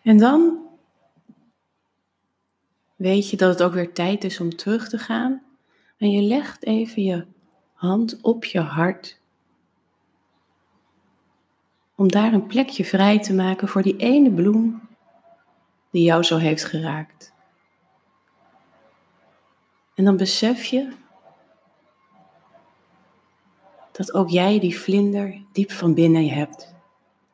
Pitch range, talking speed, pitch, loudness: 180-230 Hz, 115 wpm, 200 Hz, -20 LUFS